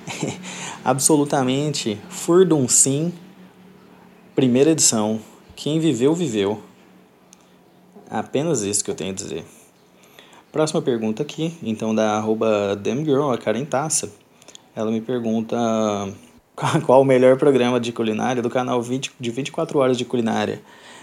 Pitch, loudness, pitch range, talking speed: 130 Hz, -20 LUFS, 110-150 Hz, 130 wpm